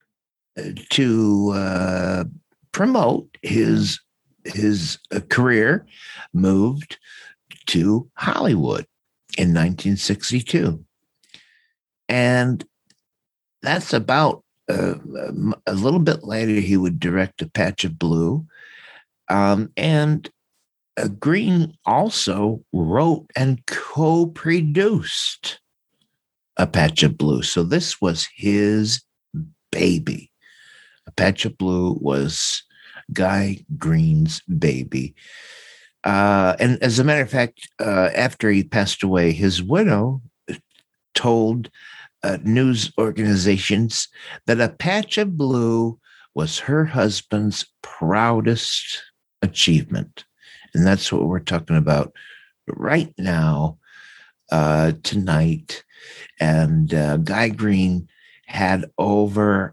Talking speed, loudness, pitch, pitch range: 95 wpm, -20 LUFS, 105 Hz, 90-135 Hz